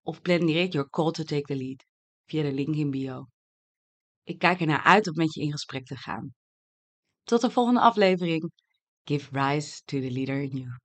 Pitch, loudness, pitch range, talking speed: 145 Hz, -26 LUFS, 135-170 Hz, 200 wpm